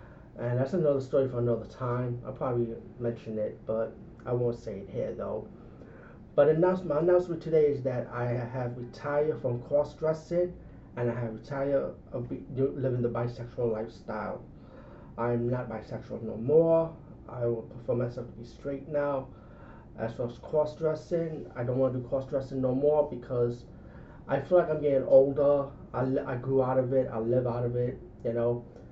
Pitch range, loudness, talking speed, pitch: 120-145 Hz, -30 LUFS, 170 wpm, 125 Hz